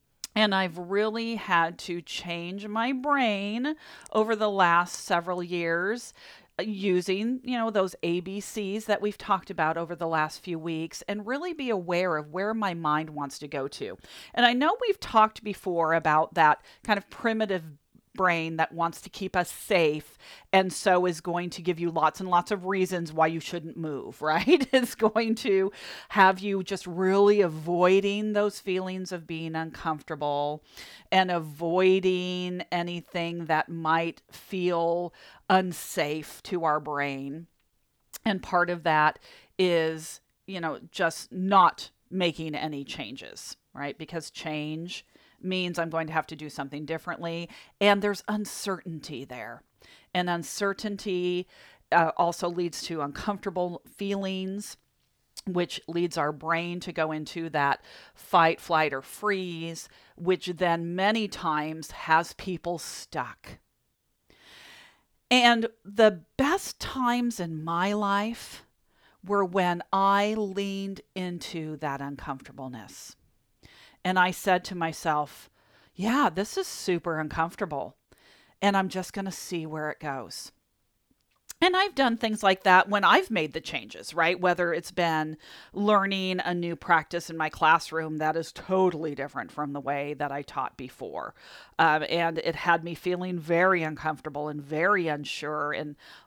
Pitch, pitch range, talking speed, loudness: 175 Hz, 160-200 Hz, 145 wpm, -27 LUFS